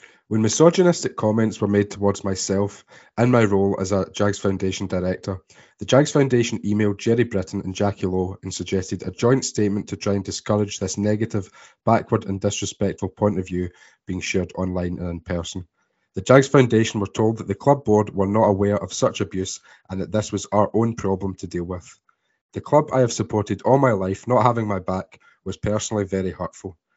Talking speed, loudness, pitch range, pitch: 195 wpm, -21 LUFS, 95-110 Hz, 100 Hz